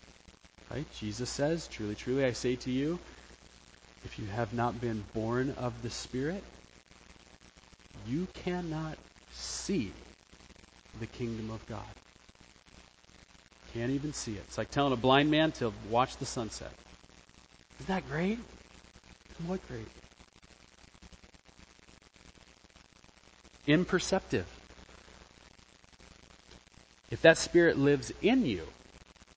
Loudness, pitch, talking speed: -32 LUFS, 110 Hz, 105 wpm